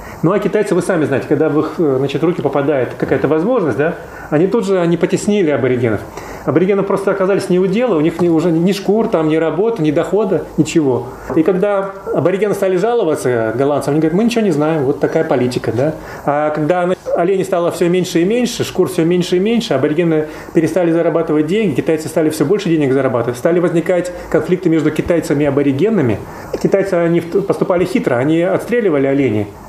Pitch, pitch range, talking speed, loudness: 170 Hz, 155-190 Hz, 185 wpm, -15 LUFS